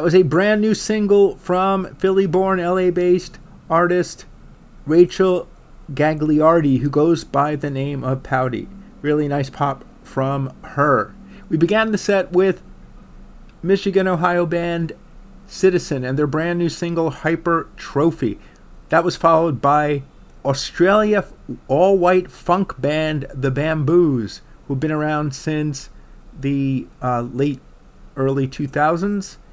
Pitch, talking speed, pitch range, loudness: 165 Hz, 125 wpm, 145-185 Hz, -19 LUFS